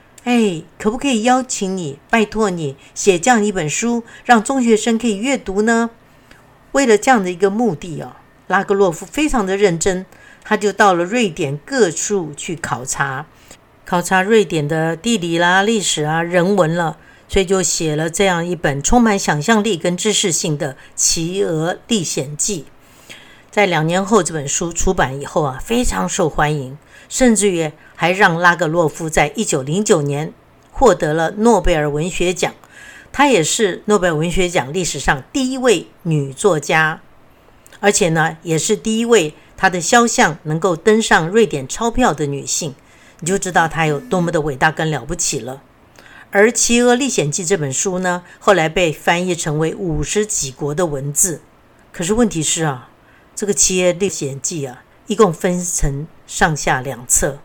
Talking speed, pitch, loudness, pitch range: 250 characters per minute, 180 Hz, -16 LUFS, 155-210 Hz